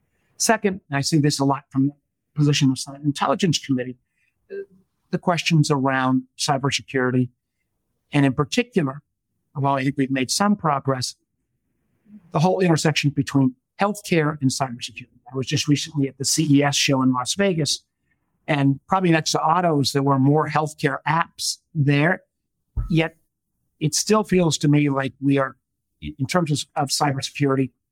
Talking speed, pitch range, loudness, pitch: 155 wpm, 135-160 Hz, -21 LUFS, 145 Hz